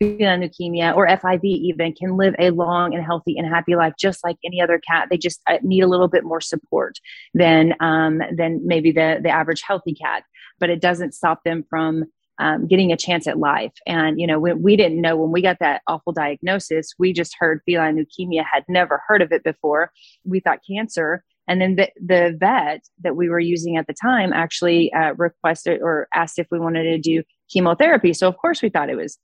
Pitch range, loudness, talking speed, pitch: 165-180 Hz, -19 LUFS, 215 wpm, 170 Hz